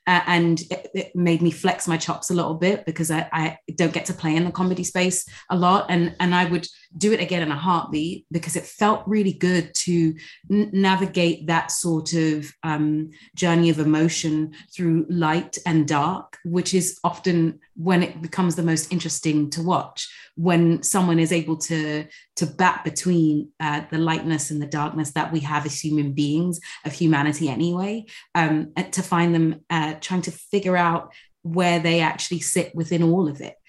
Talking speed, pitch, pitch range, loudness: 185 wpm, 170 Hz, 160-180 Hz, -22 LUFS